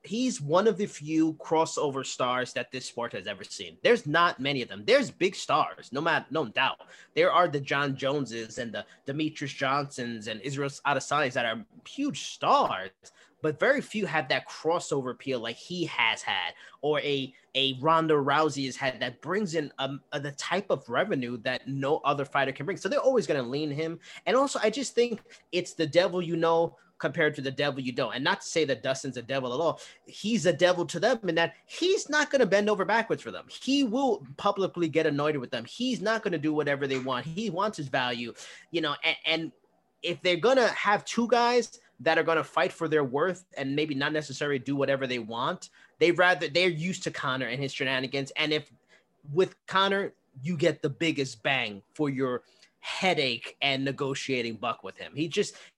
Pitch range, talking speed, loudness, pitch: 135-180 Hz, 210 wpm, -28 LUFS, 155 Hz